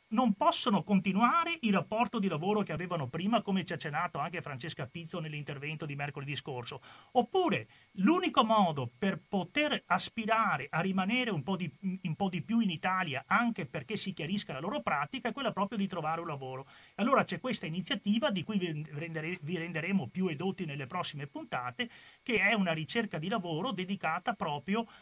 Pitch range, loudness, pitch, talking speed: 160-220 Hz, -33 LUFS, 185 Hz, 180 wpm